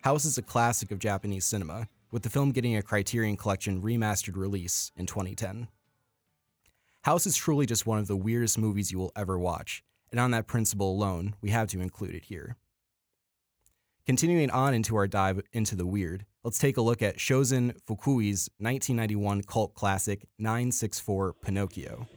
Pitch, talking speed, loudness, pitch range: 110 Hz, 170 wpm, -29 LUFS, 100-120 Hz